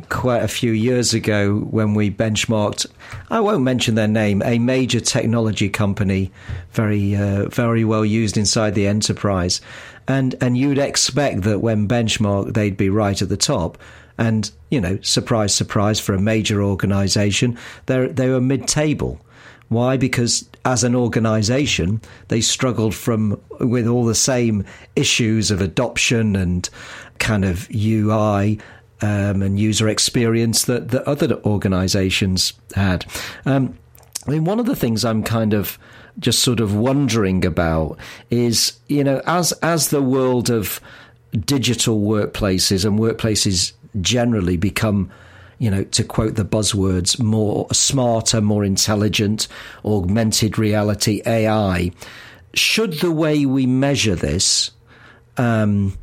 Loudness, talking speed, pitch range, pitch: -18 LUFS, 140 wpm, 100-120 Hz, 110 Hz